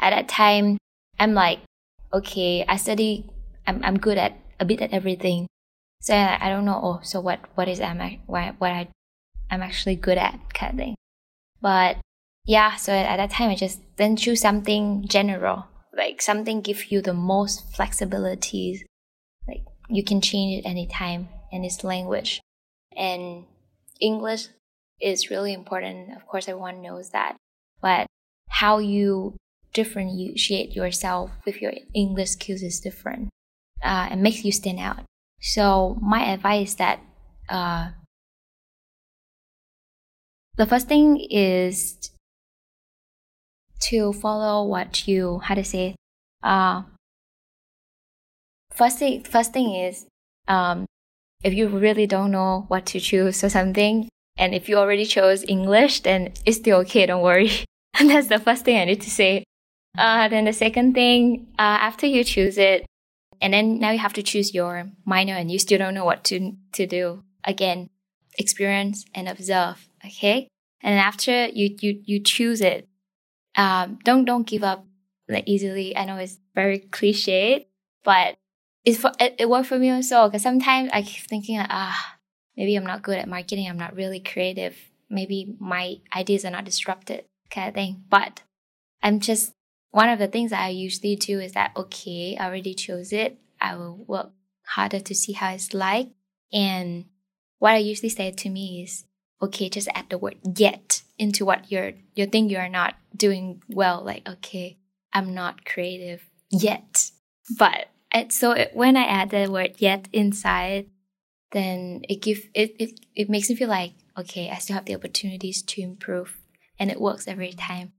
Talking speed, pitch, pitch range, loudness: 165 wpm, 195 Hz, 185-210 Hz, -22 LUFS